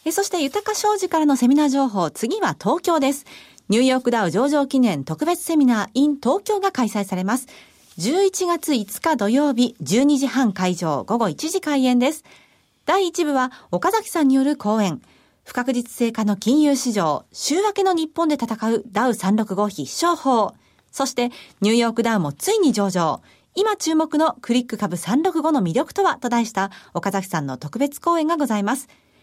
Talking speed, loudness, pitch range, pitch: 315 characters per minute, -20 LUFS, 215-320 Hz, 260 Hz